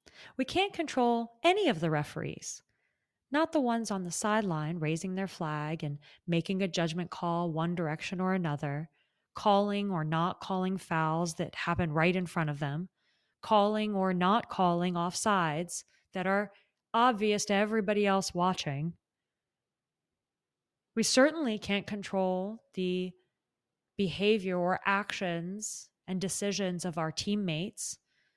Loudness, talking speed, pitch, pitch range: -31 LUFS, 130 wpm, 185 Hz, 170-210 Hz